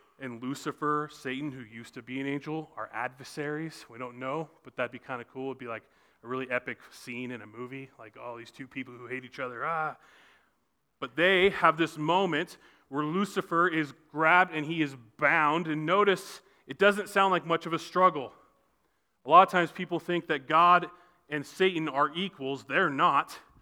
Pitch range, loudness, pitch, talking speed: 130-170 Hz, -28 LUFS, 150 Hz, 200 wpm